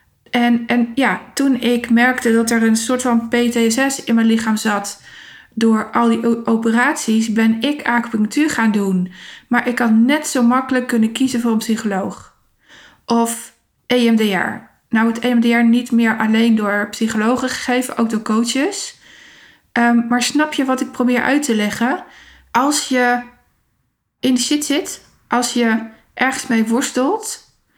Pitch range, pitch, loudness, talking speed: 225-255 Hz, 235 Hz, -16 LUFS, 155 wpm